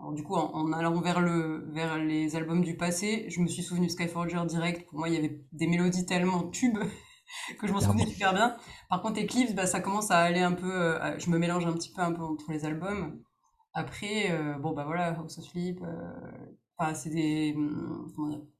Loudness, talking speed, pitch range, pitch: -30 LUFS, 225 wpm, 160-185 Hz, 170 Hz